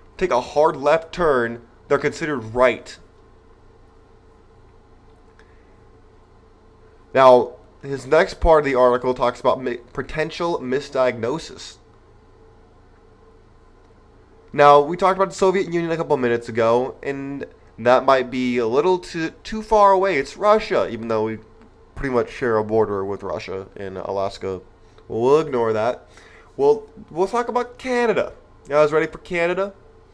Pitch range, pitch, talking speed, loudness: 100-160 Hz, 120 Hz, 135 wpm, -20 LUFS